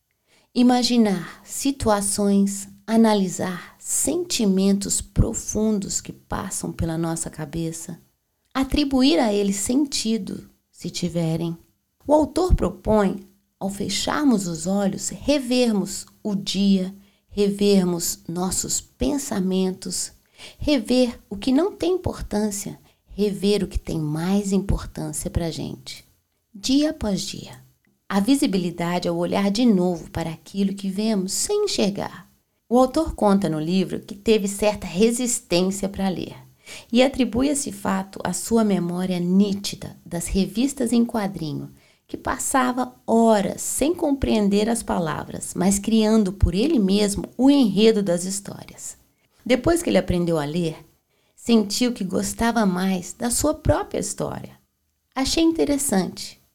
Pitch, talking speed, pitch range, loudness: 200 Hz, 120 wpm, 185-240 Hz, -22 LUFS